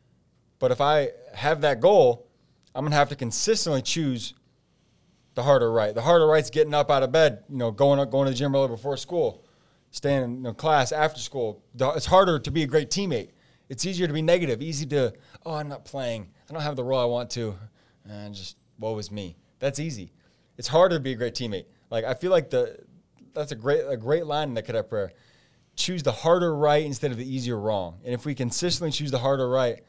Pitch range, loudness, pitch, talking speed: 125-160 Hz, -25 LUFS, 140 Hz, 230 wpm